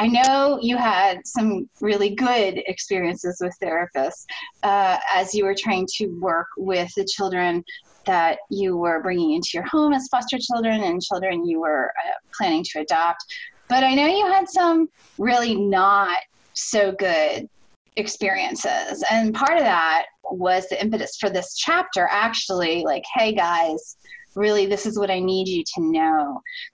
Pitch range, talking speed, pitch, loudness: 180-260 Hz, 160 wpm, 200 Hz, -21 LUFS